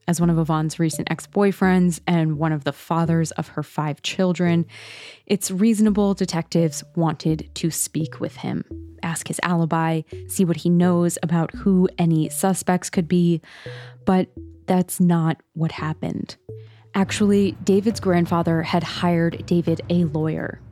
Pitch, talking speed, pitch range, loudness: 170 Hz, 145 wpm, 155-180 Hz, -21 LUFS